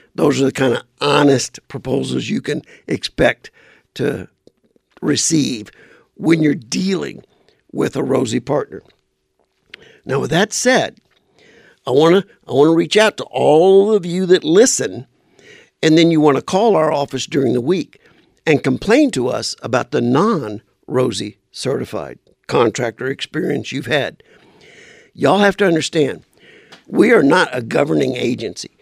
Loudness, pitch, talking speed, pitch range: -16 LUFS, 165 Hz, 145 wpm, 145-195 Hz